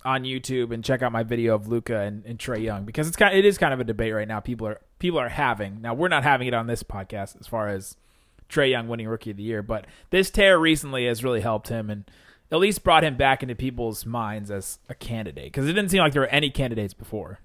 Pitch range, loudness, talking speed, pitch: 110-135 Hz, -24 LUFS, 270 wpm, 115 Hz